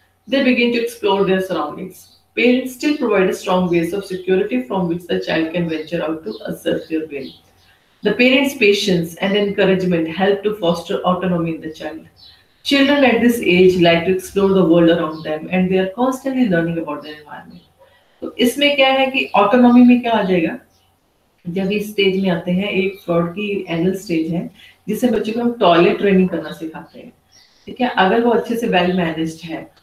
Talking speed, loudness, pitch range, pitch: 190 wpm, -16 LUFS, 170-225 Hz, 190 Hz